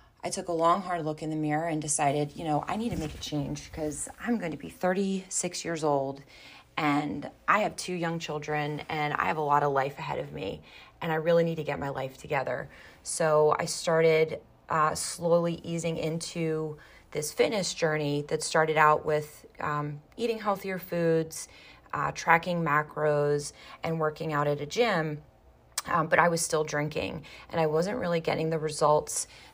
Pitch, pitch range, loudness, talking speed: 155 Hz, 150-170 Hz, -29 LUFS, 185 wpm